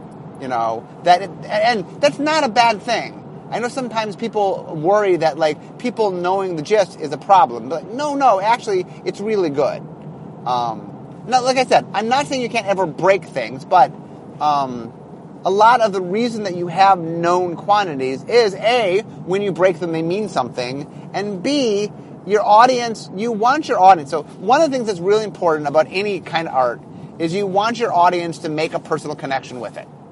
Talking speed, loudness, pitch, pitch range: 195 wpm, -18 LUFS, 195 Hz, 165-230 Hz